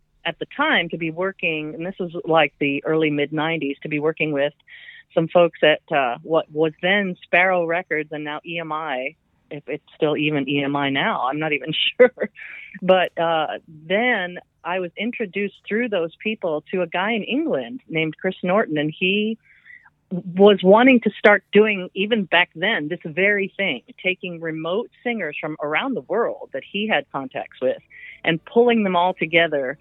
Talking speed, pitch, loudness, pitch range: 175 wpm, 180 Hz, -21 LUFS, 155-205 Hz